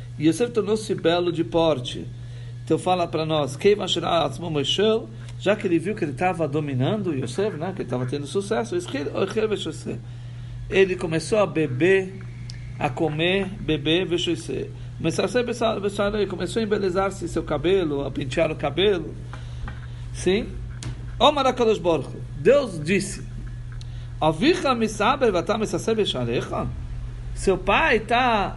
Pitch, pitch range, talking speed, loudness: 160 Hz, 120-195 Hz, 110 wpm, -23 LUFS